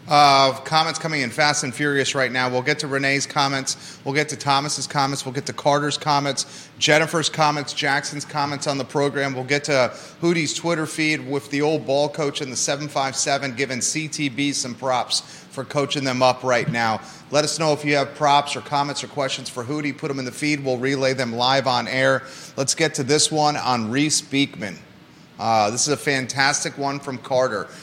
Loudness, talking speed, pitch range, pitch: -21 LUFS, 205 wpm, 135-150 Hz, 140 Hz